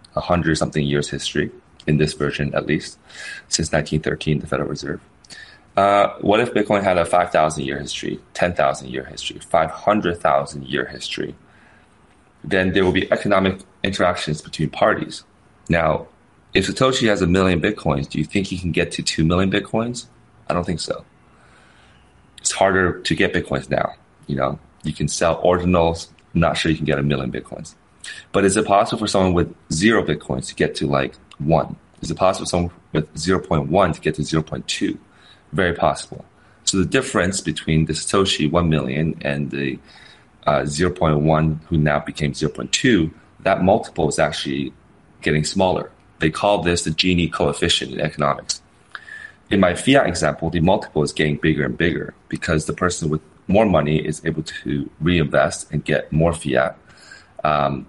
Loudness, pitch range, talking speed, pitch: -20 LUFS, 75-90 Hz, 170 wpm, 80 Hz